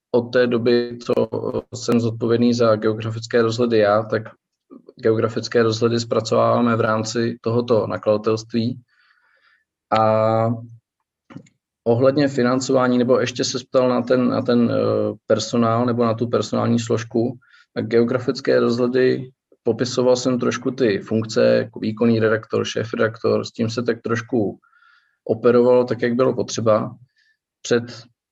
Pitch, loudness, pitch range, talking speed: 120 Hz, -20 LUFS, 115-125 Hz, 125 wpm